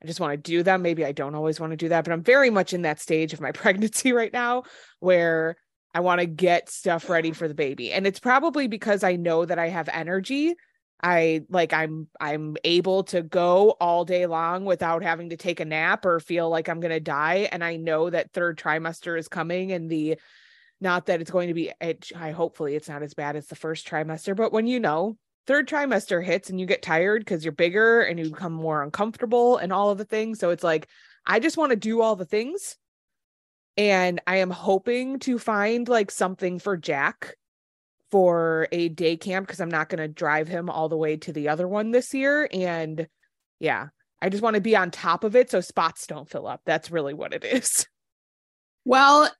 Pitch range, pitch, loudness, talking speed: 165-210 Hz, 175 Hz, -24 LUFS, 220 wpm